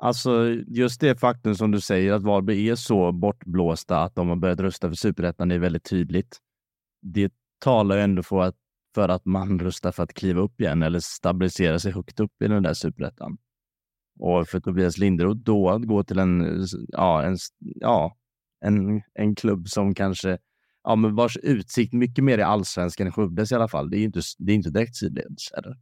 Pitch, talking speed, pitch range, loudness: 100 Hz, 200 wpm, 90-110 Hz, -24 LUFS